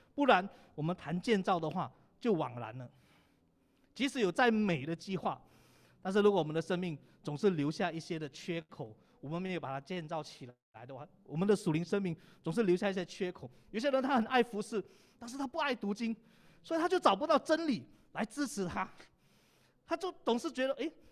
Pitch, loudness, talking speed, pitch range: 195 Hz, -34 LUFS, 290 characters per minute, 165-240 Hz